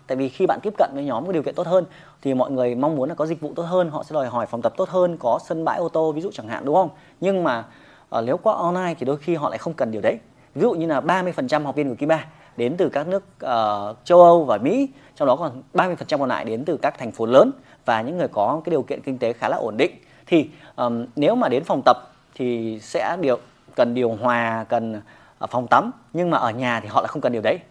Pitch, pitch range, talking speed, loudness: 160 Hz, 125-180 Hz, 275 wpm, -22 LUFS